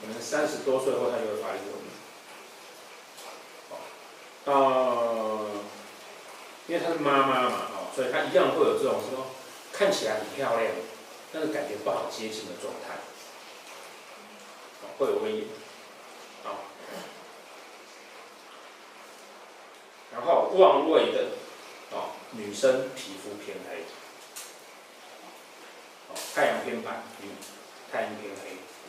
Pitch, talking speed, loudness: 150 Hz, 145 characters per minute, -28 LUFS